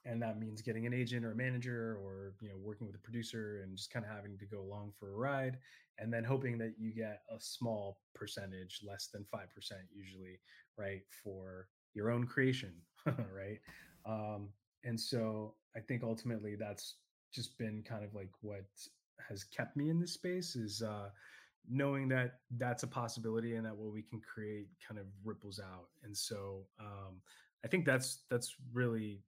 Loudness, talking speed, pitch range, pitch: -42 LUFS, 185 wpm, 100-120 Hz, 110 Hz